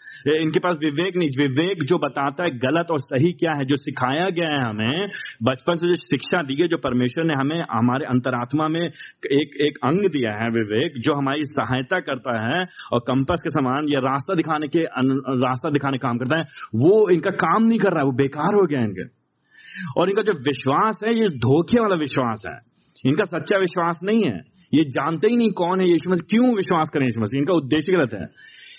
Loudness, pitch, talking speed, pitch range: -21 LUFS, 155 Hz, 210 wpm, 135-180 Hz